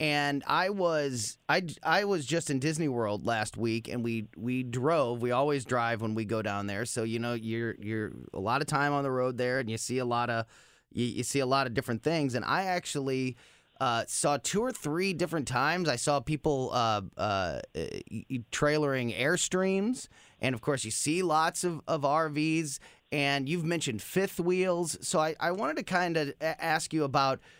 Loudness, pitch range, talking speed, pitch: -30 LUFS, 120-160 Hz, 200 wpm, 140 Hz